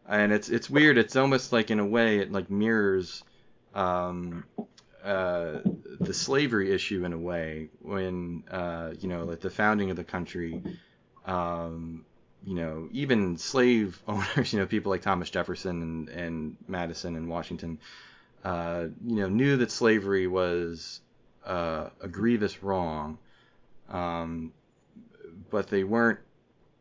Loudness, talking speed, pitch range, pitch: -28 LUFS, 140 wpm, 85-105 Hz, 95 Hz